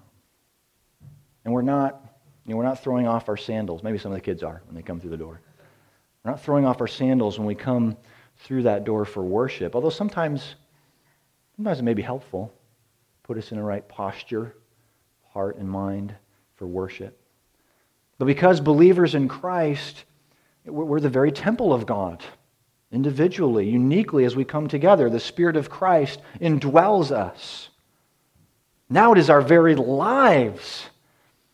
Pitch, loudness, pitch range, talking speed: 130 Hz, -22 LUFS, 110-150 Hz, 160 wpm